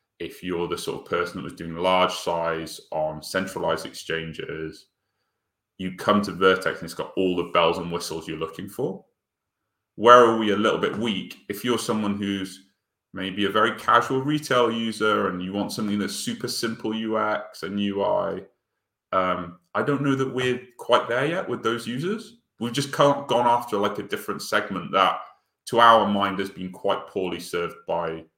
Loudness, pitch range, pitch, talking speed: -24 LUFS, 90-120 Hz, 100 Hz, 185 wpm